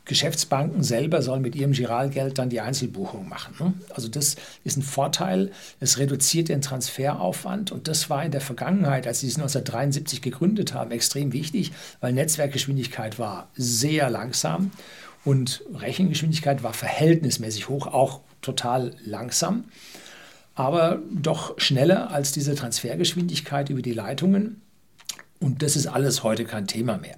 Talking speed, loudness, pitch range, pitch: 140 wpm, -24 LUFS, 125-155 Hz, 140 Hz